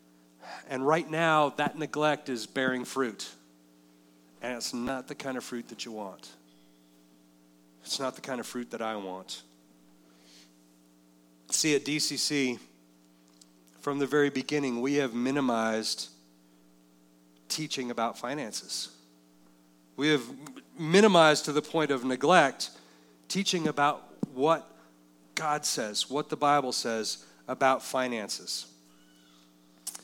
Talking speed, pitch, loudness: 120 wpm, 100 Hz, -29 LUFS